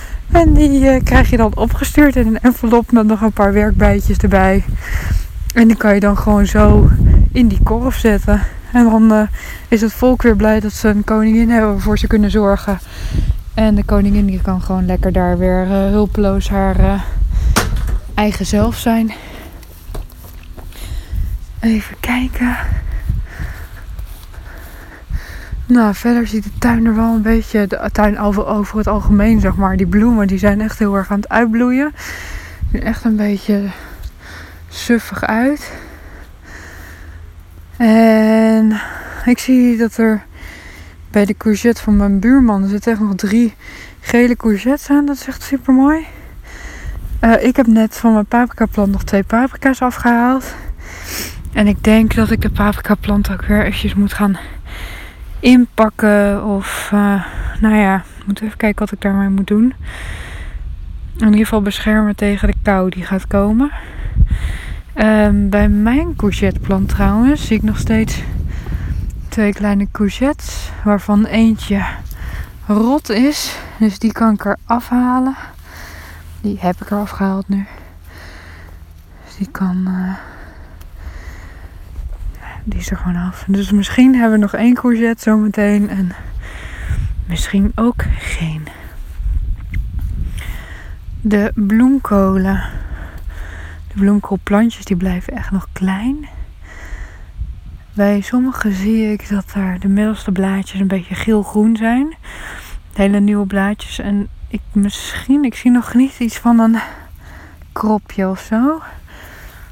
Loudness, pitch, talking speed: -14 LUFS, 205 Hz, 140 wpm